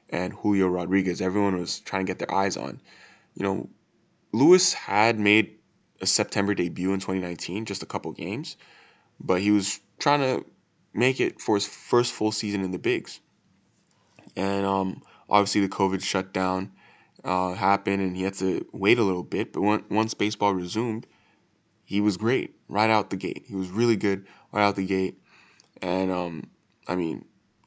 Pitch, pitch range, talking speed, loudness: 95 Hz, 95-105 Hz, 175 wpm, -25 LUFS